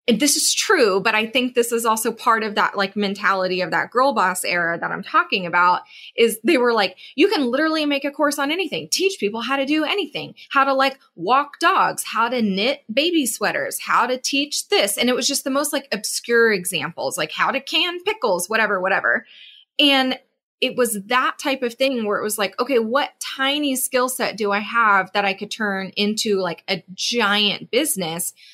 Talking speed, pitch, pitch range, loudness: 210 wpm, 245 Hz, 205-280 Hz, -19 LUFS